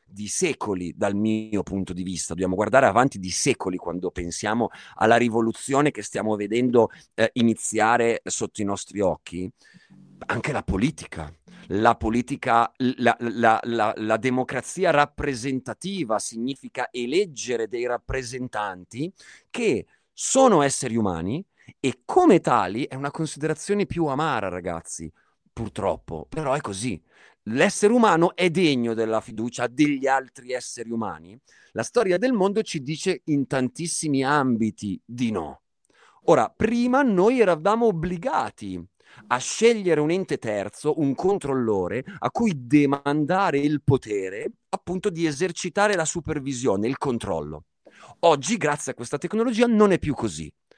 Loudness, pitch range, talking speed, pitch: -24 LUFS, 110-165 Hz, 130 wpm, 130 Hz